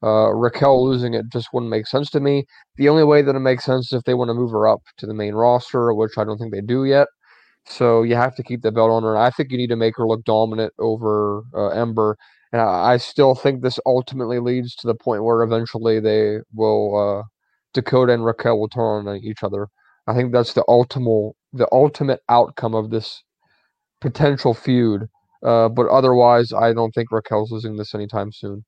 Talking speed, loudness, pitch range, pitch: 220 wpm, -18 LUFS, 110-125 Hz, 115 Hz